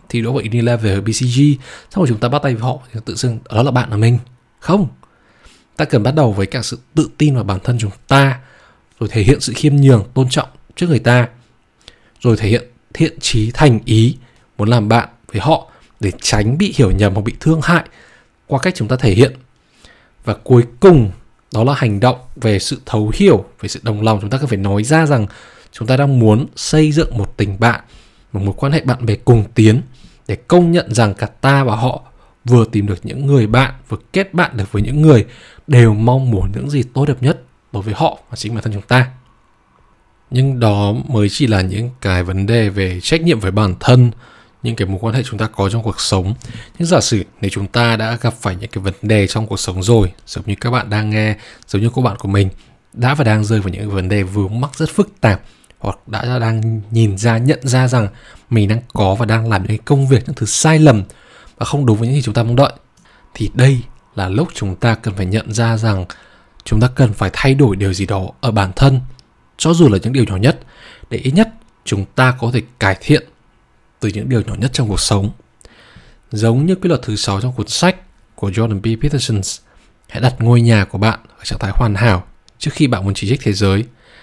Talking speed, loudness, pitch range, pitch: 235 wpm, -15 LUFS, 105-130 Hz, 115 Hz